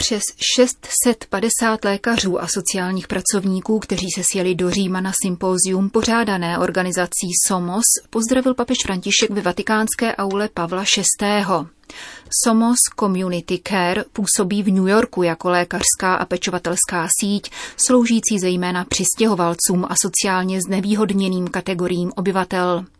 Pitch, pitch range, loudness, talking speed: 195 Hz, 180-215 Hz, -18 LUFS, 115 wpm